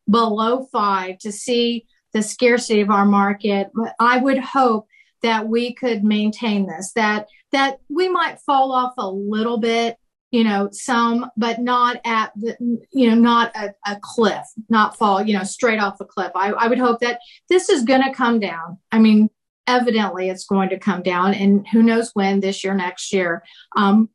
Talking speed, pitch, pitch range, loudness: 185 wpm, 225 Hz, 200-240 Hz, -19 LUFS